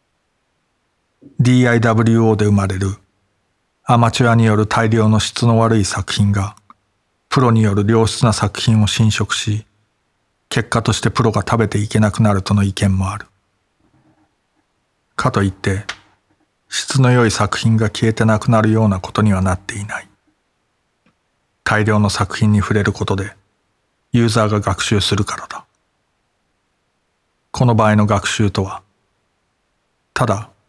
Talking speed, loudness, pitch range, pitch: 260 characters per minute, -16 LUFS, 100-115 Hz, 105 Hz